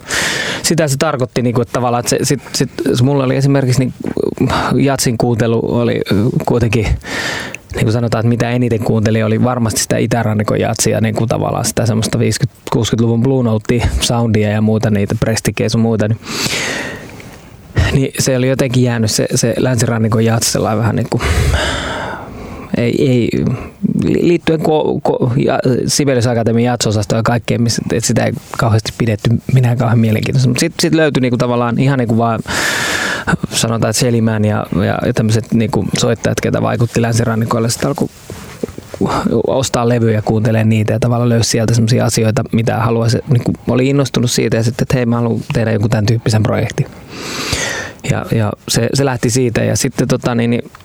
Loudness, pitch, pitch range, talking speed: -14 LUFS, 120 Hz, 110-130 Hz, 160 wpm